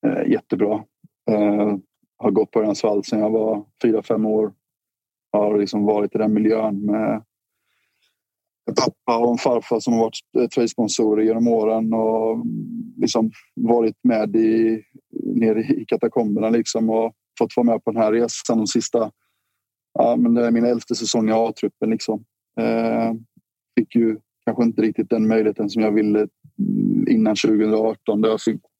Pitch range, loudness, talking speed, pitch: 110-115 Hz, -20 LUFS, 155 wpm, 110 Hz